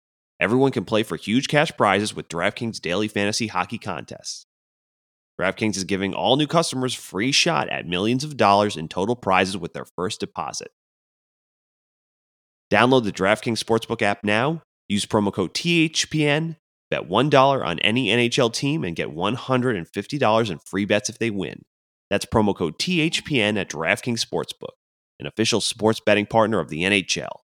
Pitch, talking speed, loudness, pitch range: 110 Hz, 155 wpm, -22 LUFS, 100-130 Hz